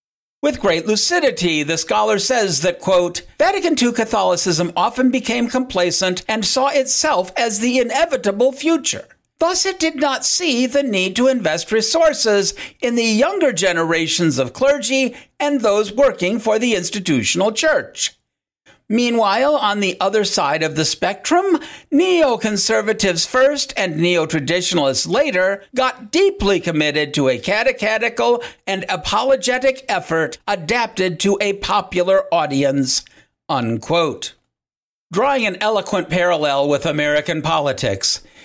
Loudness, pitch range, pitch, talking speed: -17 LUFS, 180-265 Hz, 215 Hz, 125 wpm